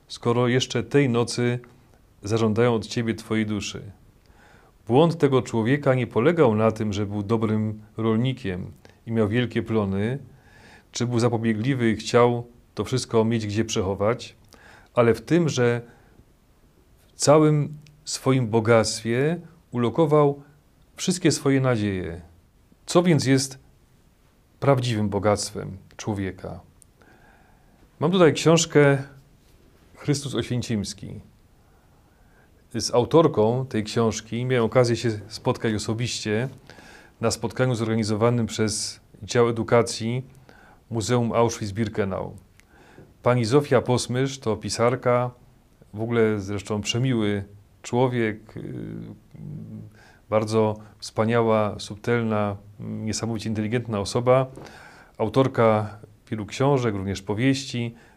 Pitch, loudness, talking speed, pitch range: 115 Hz, -23 LUFS, 100 wpm, 105-125 Hz